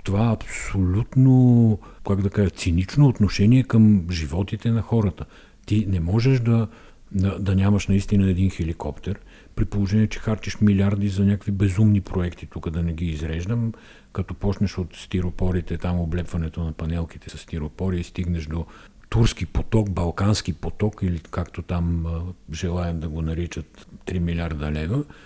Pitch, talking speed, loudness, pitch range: 95 Hz, 145 wpm, -23 LUFS, 85-105 Hz